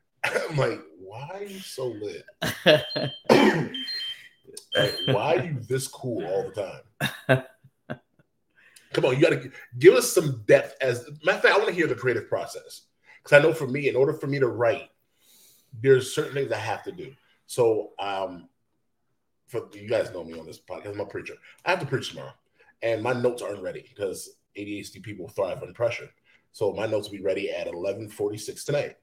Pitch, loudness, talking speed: 150 Hz, -25 LUFS, 190 wpm